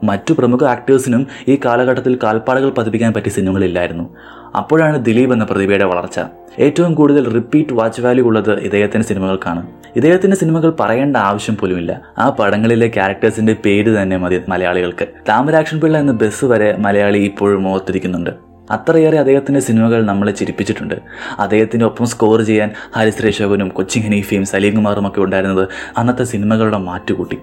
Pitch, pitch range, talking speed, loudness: 110 Hz, 100-125 Hz, 130 wpm, -14 LUFS